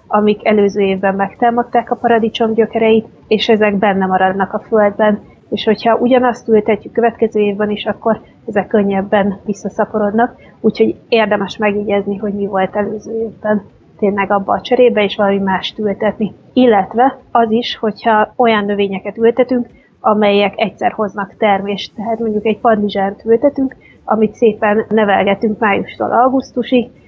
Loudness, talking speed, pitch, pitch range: -14 LUFS, 135 wpm, 215 Hz, 205-230 Hz